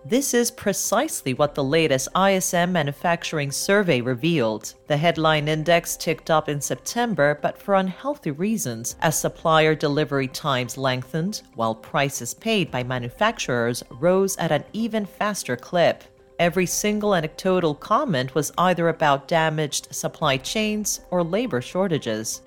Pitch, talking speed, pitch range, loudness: 160 Hz, 135 wpm, 135-185 Hz, -22 LUFS